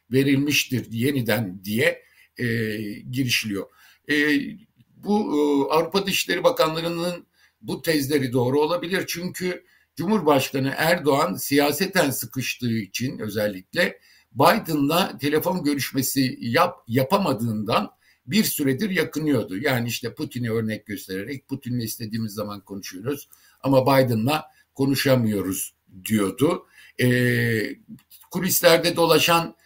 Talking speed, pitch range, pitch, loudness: 95 wpm, 115-160 Hz, 135 Hz, -23 LUFS